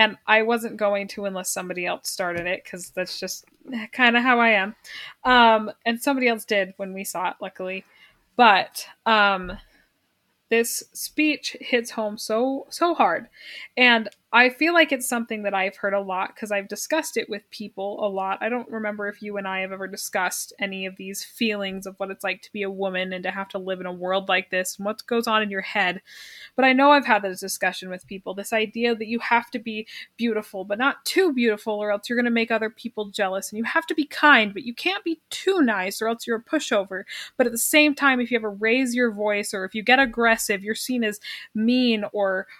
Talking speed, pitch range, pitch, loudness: 230 wpm, 195-240 Hz, 215 Hz, -23 LUFS